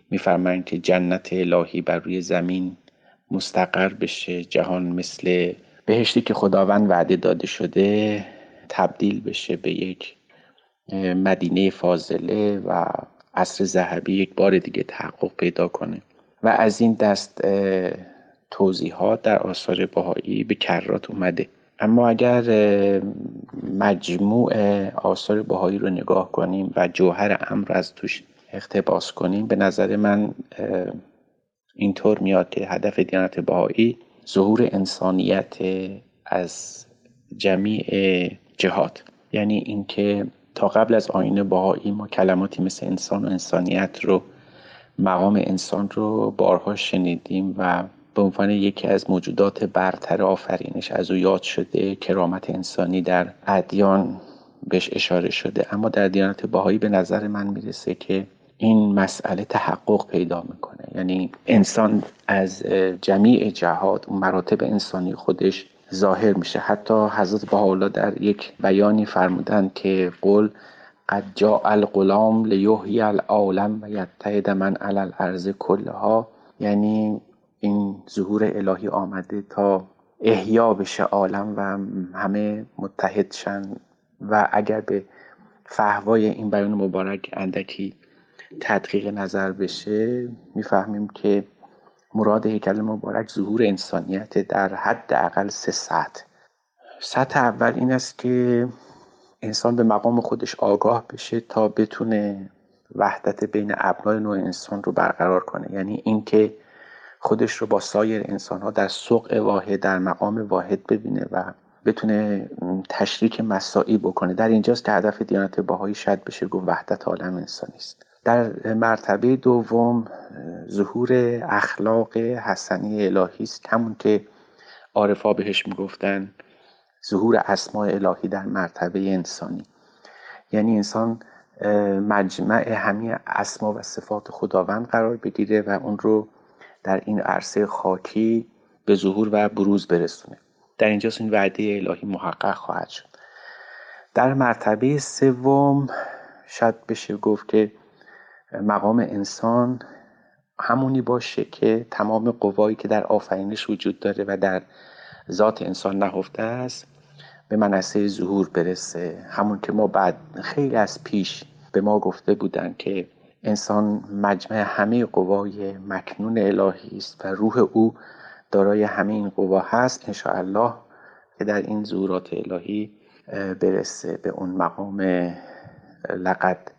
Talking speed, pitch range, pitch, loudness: 125 wpm, 95-110 Hz, 100 Hz, -22 LUFS